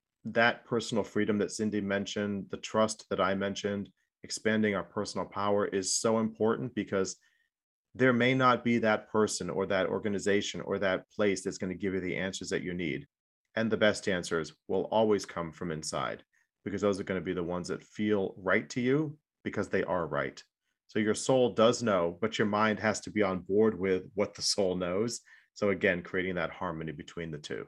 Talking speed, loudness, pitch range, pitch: 200 wpm, -31 LUFS, 95-110 Hz, 100 Hz